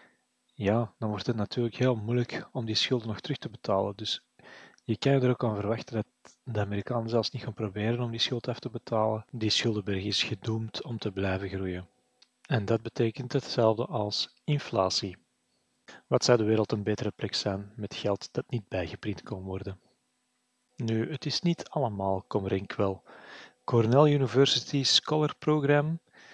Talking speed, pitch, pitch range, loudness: 170 wpm, 115 Hz, 105-125 Hz, -29 LUFS